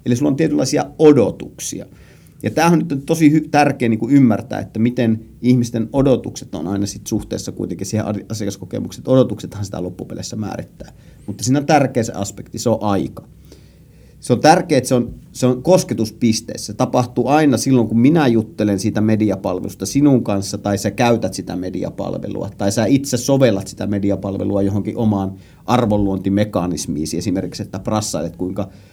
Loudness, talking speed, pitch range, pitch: -18 LUFS, 160 wpm, 100-125 Hz, 110 Hz